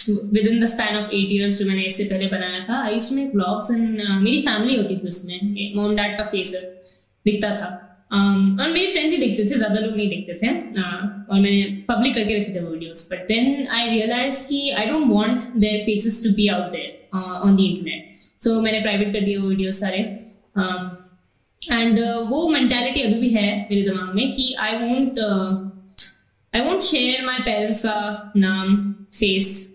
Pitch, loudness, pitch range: 210 Hz, -20 LUFS, 195-230 Hz